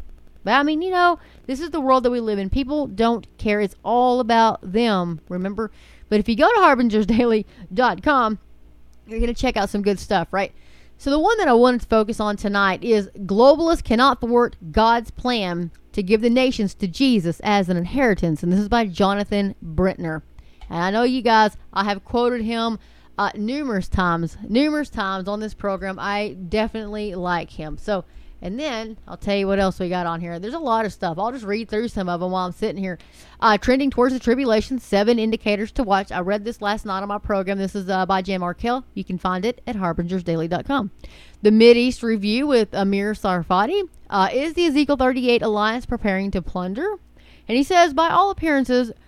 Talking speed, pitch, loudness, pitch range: 205 wpm, 215 Hz, -20 LUFS, 195-245 Hz